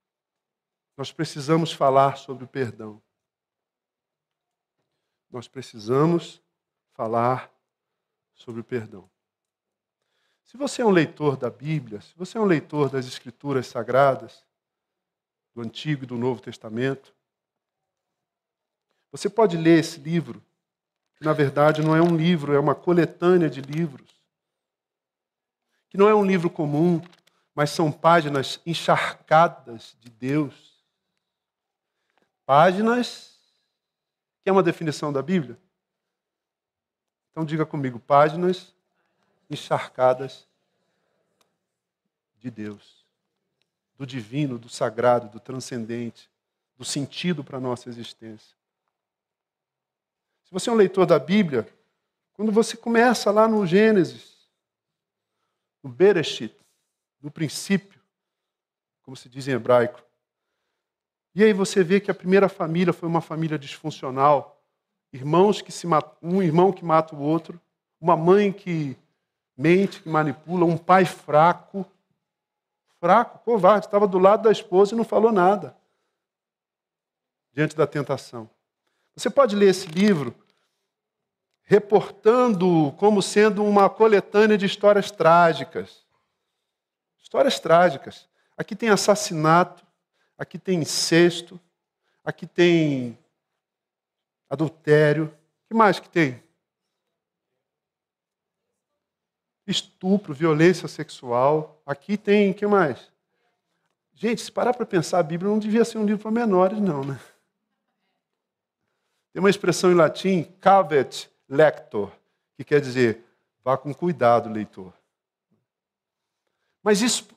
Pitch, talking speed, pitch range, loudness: 165 Hz, 115 wpm, 140-195 Hz, -21 LUFS